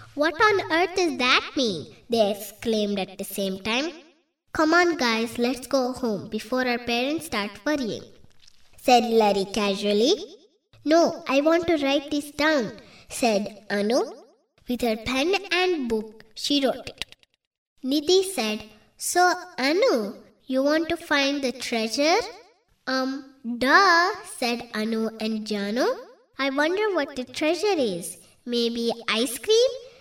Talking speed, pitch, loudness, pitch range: 135 wpm, 265 Hz, -24 LUFS, 225-335 Hz